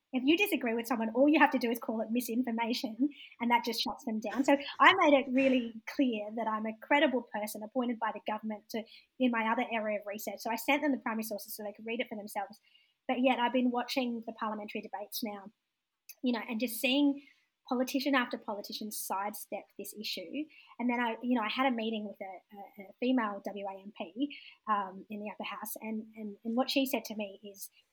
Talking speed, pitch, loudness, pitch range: 225 wpm, 230 Hz, -32 LUFS, 215-260 Hz